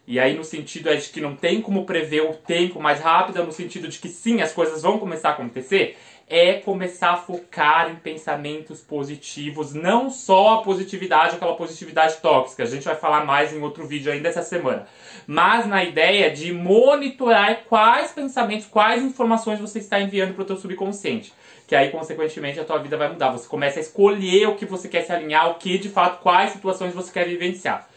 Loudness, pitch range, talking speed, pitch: -20 LUFS, 155-195 Hz, 200 wpm, 175 Hz